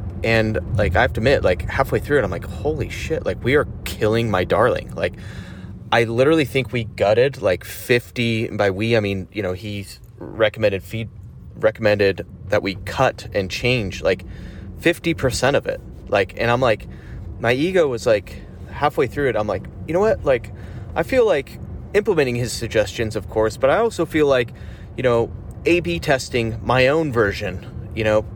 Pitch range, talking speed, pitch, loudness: 100-125 Hz, 185 wpm, 110 Hz, -20 LUFS